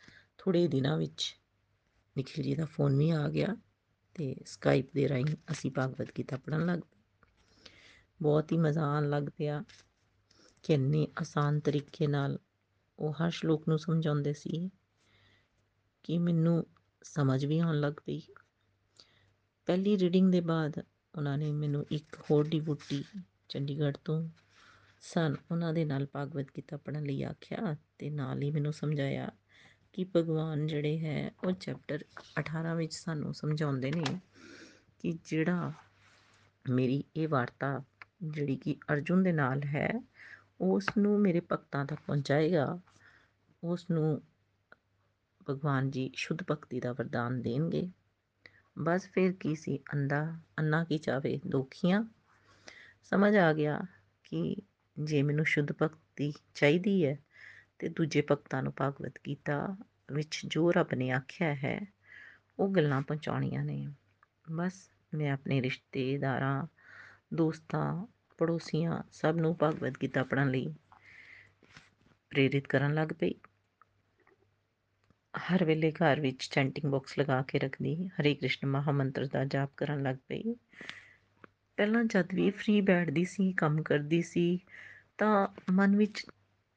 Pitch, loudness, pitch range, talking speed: 150 Hz, -32 LUFS, 135-165 Hz, 130 wpm